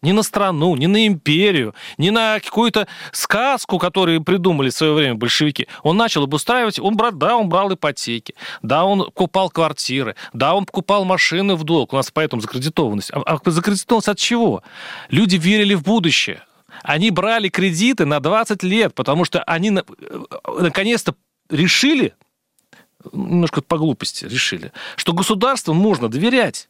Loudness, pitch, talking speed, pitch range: -17 LUFS, 185 Hz, 155 wpm, 155-210 Hz